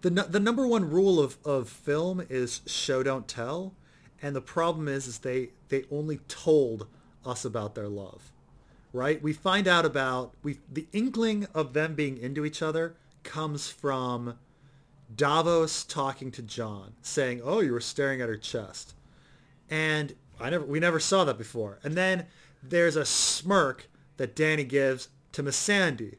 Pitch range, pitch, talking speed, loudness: 125-160 Hz, 145 Hz, 165 wpm, -28 LUFS